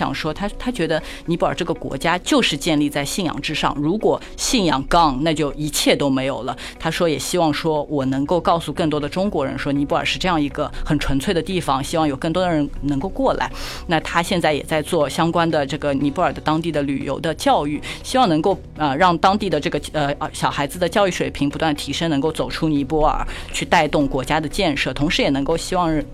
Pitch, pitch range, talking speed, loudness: 155 Hz, 145-170 Hz, 340 characters per minute, -20 LUFS